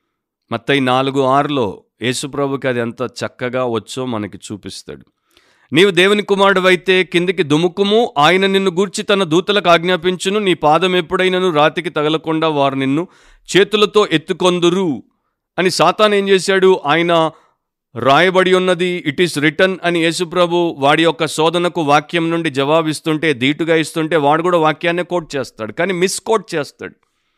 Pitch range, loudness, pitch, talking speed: 145-185 Hz, -15 LUFS, 170 Hz, 130 wpm